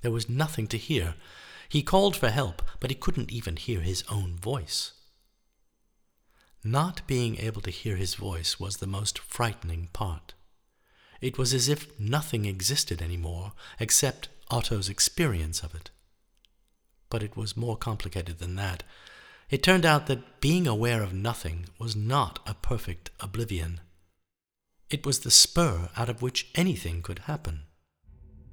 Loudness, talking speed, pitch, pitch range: -28 LUFS, 150 wpm, 105 Hz, 90-130 Hz